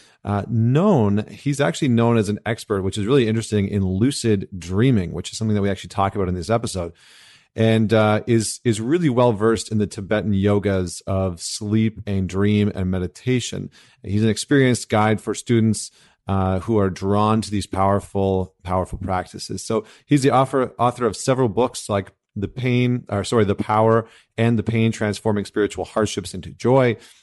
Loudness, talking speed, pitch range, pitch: -21 LUFS, 180 wpm, 100-115 Hz, 105 Hz